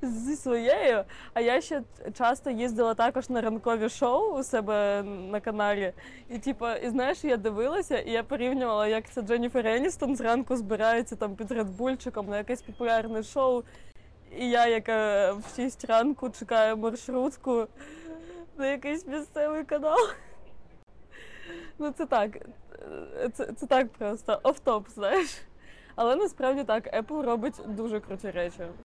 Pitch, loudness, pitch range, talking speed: 240 Hz, -28 LUFS, 220-275 Hz, 135 wpm